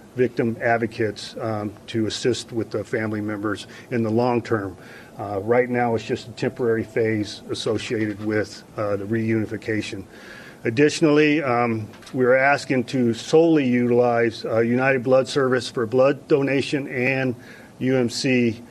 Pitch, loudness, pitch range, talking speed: 115 Hz, -22 LUFS, 110-130 Hz, 135 wpm